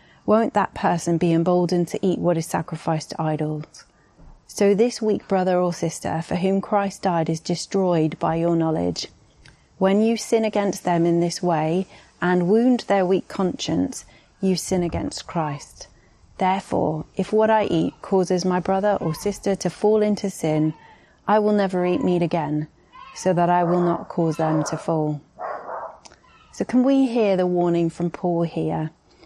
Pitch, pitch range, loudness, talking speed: 180 Hz, 165-200 Hz, -22 LUFS, 170 wpm